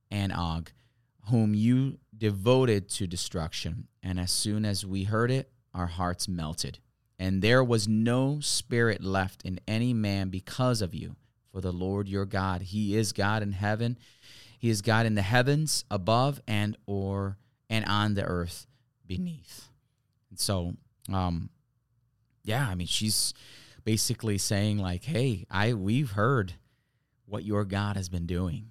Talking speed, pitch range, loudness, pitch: 150 wpm, 95-120 Hz, -29 LUFS, 105 Hz